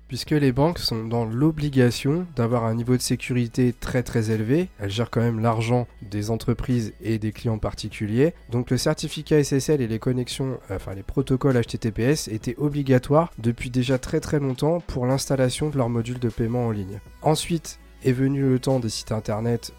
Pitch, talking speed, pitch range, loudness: 125 Hz, 180 wpm, 115-140 Hz, -24 LUFS